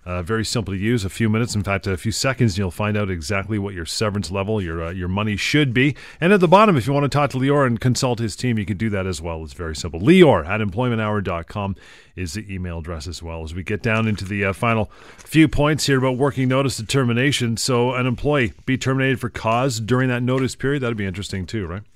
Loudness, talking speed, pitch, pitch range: -20 LUFS, 250 wpm, 110 Hz, 95-130 Hz